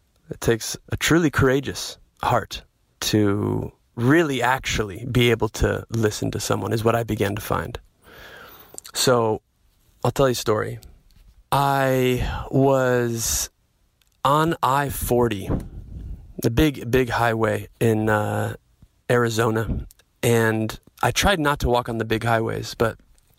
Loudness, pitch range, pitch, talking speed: -22 LUFS, 105-130 Hz, 115 Hz, 130 wpm